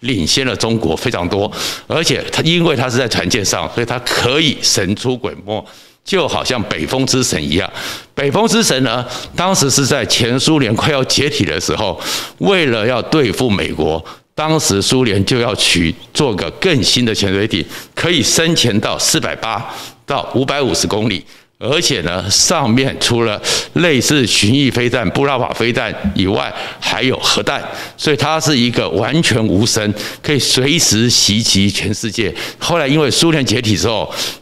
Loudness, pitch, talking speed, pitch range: -14 LUFS, 120 Hz, 255 characters per minute, 105-140 Hz